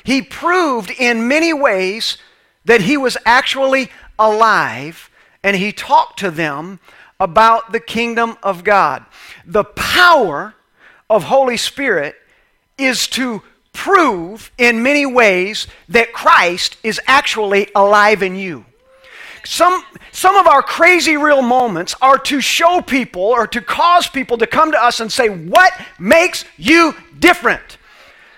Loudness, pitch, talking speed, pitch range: -13 LUFS, 245 Hz, 135 wpm, 210-305 Hz